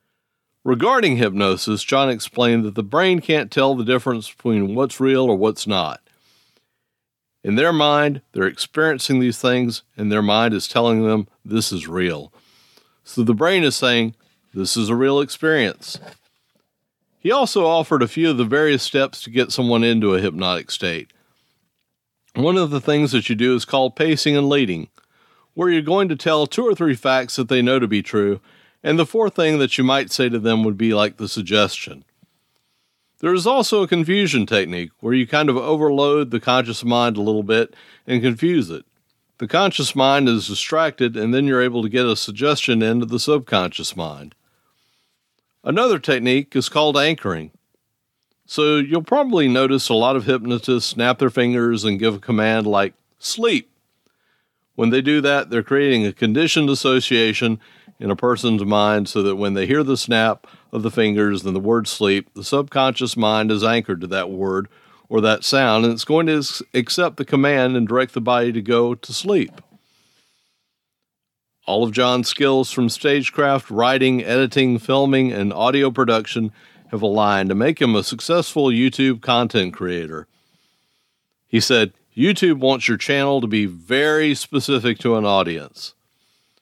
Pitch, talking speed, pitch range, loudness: 125 Hz, 170 wpm, 110-140 Hz, -18 LUFS